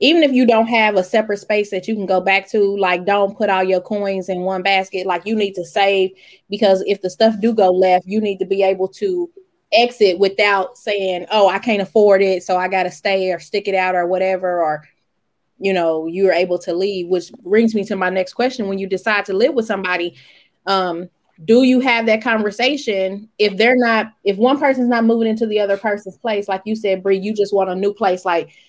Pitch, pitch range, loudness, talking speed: 195 Hz, 185-220 Hz, -17 LUFS, 230 wpm